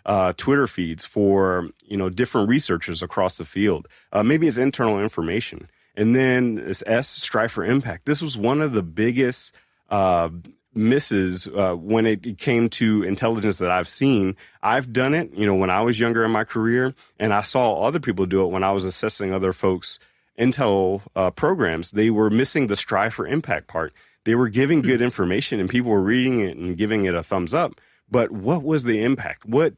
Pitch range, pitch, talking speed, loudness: 95-125 Hz, 110 Hz, 195 wpm, -21 LUFS